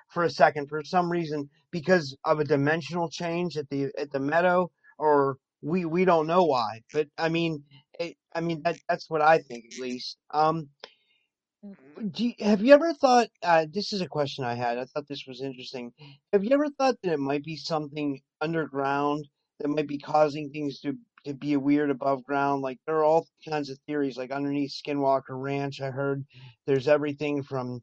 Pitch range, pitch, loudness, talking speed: 140-165 Hz, 150 Hz, -27 LUFS, 195 wpm